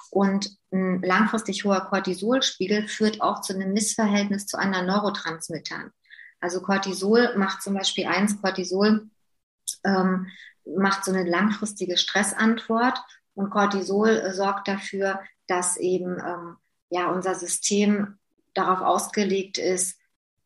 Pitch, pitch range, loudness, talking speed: 195 Hz, 185-205 Hz, -24 LUFS, 115 wpm